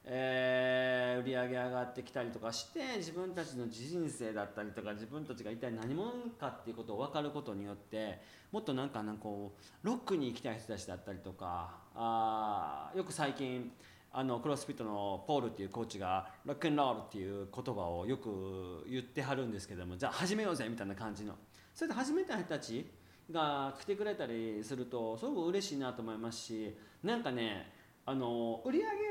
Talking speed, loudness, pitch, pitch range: 400 characters per minute, -39 LUFS, 120 Hz, 105-145 Hz